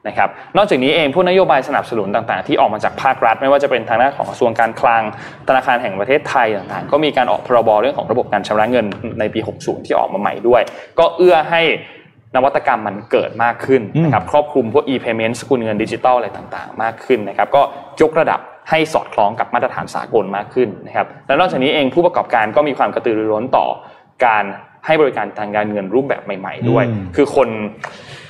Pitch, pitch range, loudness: 120 Hz, 105-145 Hz, -16 LUFS